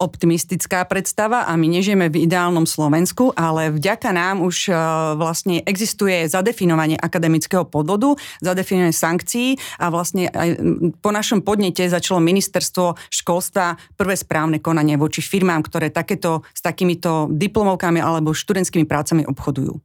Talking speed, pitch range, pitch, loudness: 125 wpm, 160-190 Hz, 175 Hz, -18 LUFS